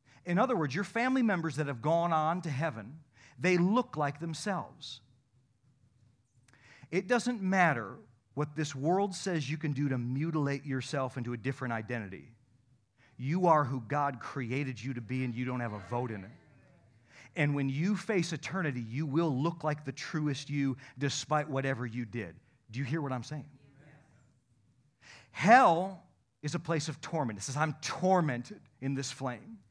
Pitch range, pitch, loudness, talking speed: 125-160 Hz, 140 Hz, -32 LUFS, 170 wpm